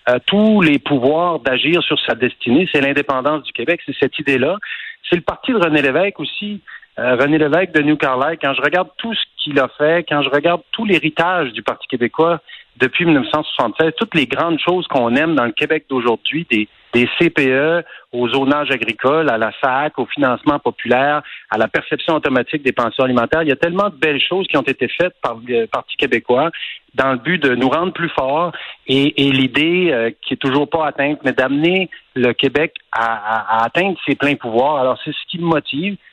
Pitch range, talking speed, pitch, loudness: 130-170 Hz, 205 wpm, 150 Hz, -16 LUFS